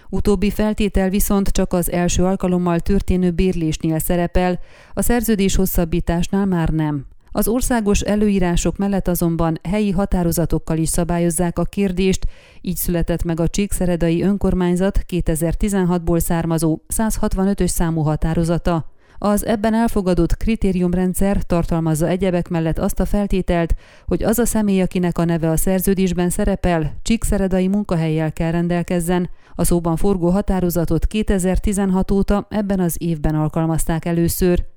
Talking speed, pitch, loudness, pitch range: 125 wpm, 180 Hz, -19 LUFS, 170-195 Hz